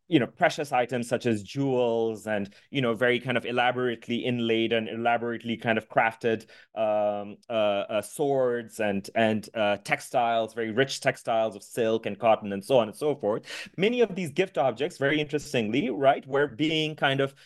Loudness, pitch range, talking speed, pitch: -27 LUFS, 110-135 Hz, 180 wpm, 120 Hz